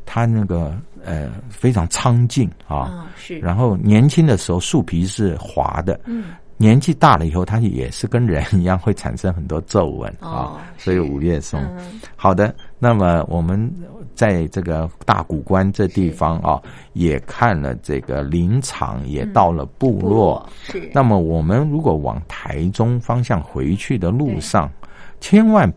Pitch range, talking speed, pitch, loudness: 85-120 Hz, 225 characters per minute, 95 Hz, -18 LUFS